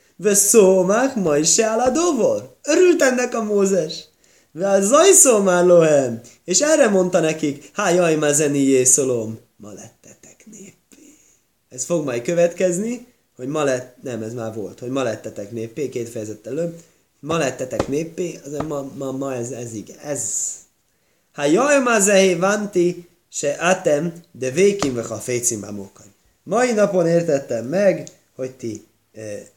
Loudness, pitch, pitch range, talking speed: -18 LUFS, 165 Hz, 125-200 Hz, 140 wpm